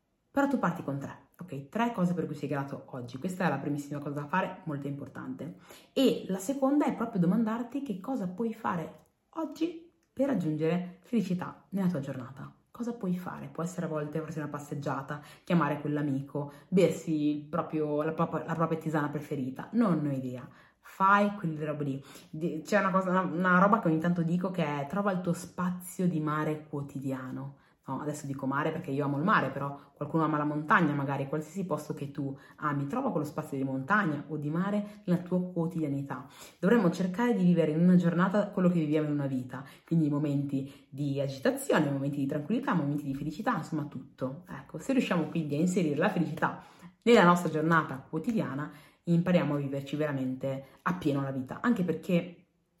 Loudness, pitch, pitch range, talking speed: -30 LUFS, 160 Hz, 145-185 Hz, 185 wpm